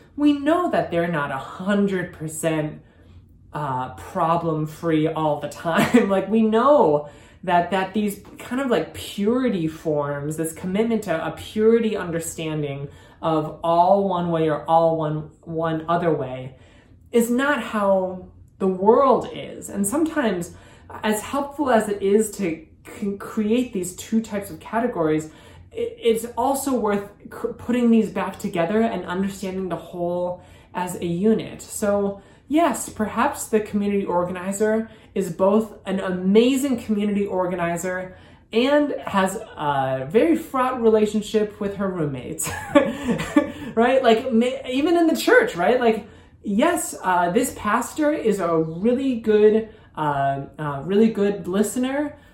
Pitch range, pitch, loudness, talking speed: 165-230 Hz, 200 Hz, -22 LUFS, 135 wpm